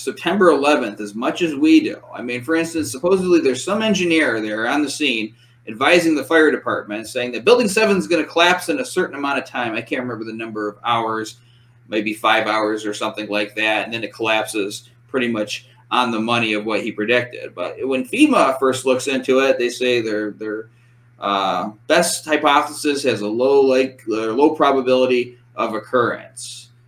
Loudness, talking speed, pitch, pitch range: -18 LUFS, 195 wpm, 125 Hz, 110-150 Hz